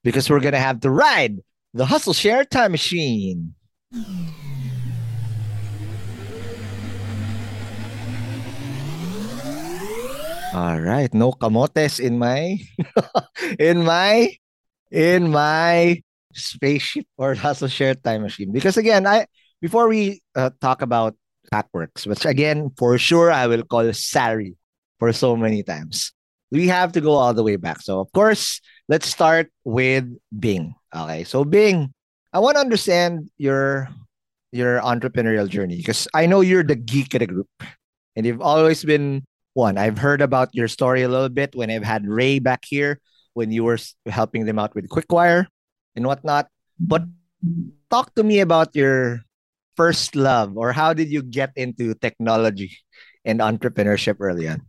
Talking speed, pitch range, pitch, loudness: 145 wpm, 115-160 Hz, 130 Hz, -20 LUFS